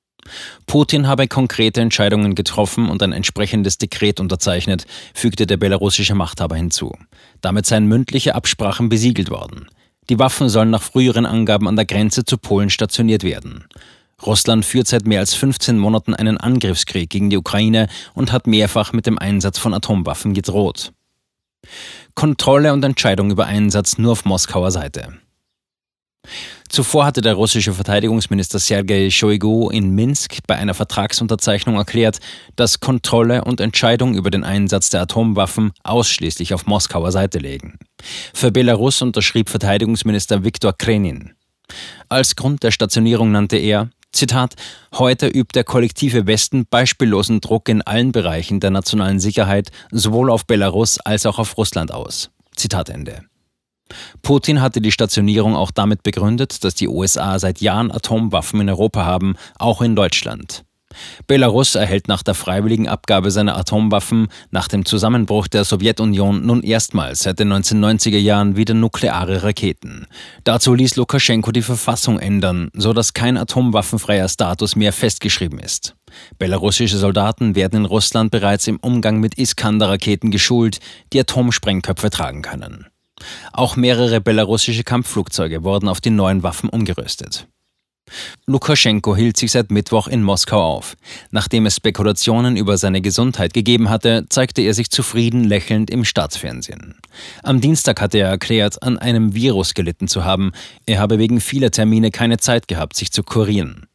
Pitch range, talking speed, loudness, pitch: 100-115 Hz, 145 wpm, -16 LUFS, 110 Hz